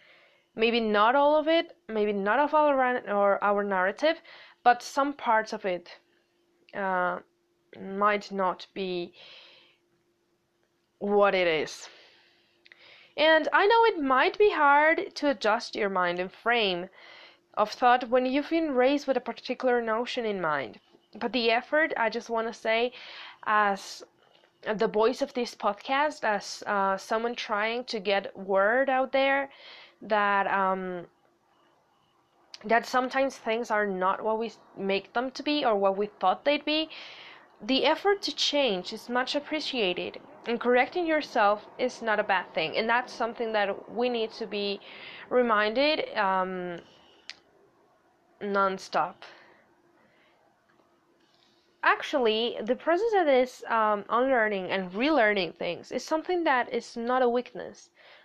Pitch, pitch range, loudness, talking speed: 235 Hz, 205-285 Hz, -27 LUFS, 140 wpm